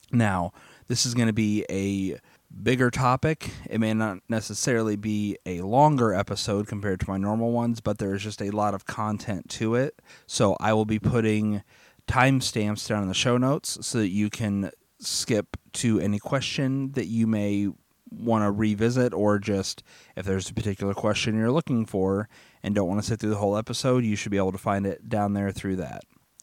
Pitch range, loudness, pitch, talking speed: 100-120 Hz, -26 LUFS, 105 Hz, 200 wpm